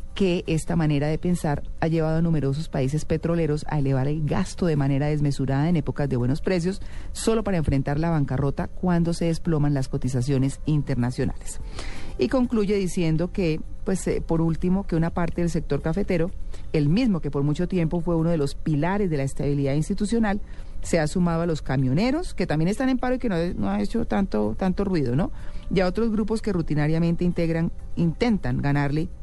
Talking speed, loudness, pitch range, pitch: 190 wpm, -24 LUFS, 145-185 Hz, 165 Hz